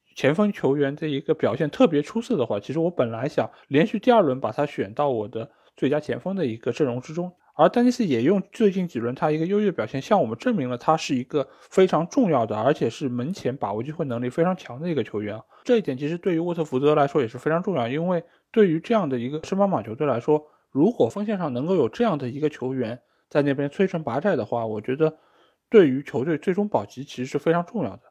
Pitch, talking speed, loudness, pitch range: 155 Hz, 370 characters per minute, -24 LUFS, 130-190 Hz